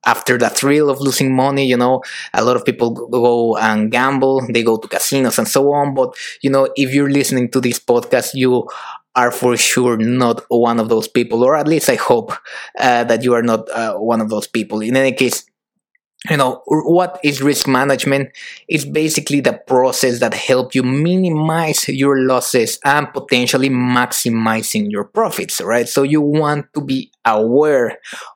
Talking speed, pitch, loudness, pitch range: 180 wpm, 130 Hz, -15 LUFS, 120-145 Hz